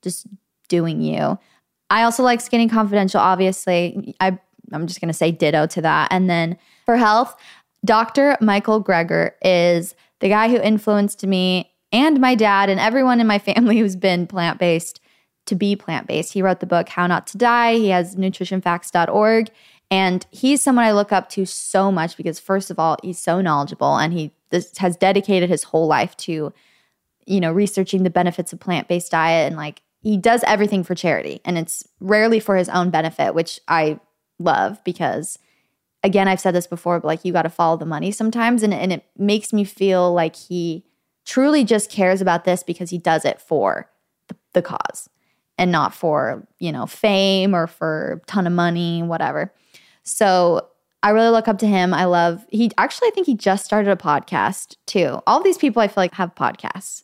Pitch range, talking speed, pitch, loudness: 170-210 Hz, 190 wpm, 185 Hz, -18 LUFS